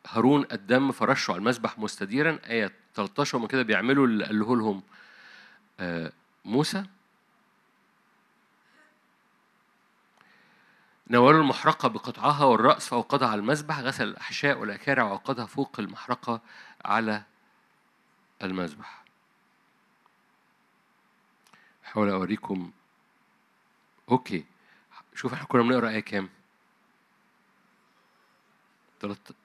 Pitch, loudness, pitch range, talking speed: 115 Hz, -26 LUFS, 105-135 Hz, 75 wpm